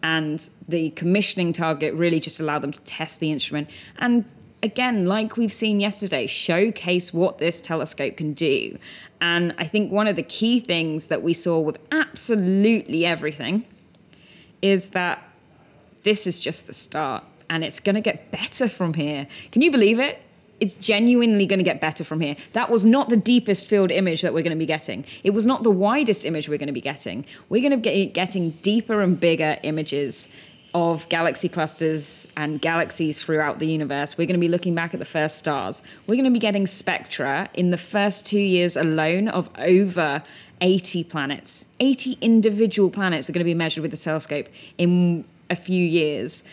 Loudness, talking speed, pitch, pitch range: -22 LUFS, 190 wpm, 175 Hz, 160-205 Hz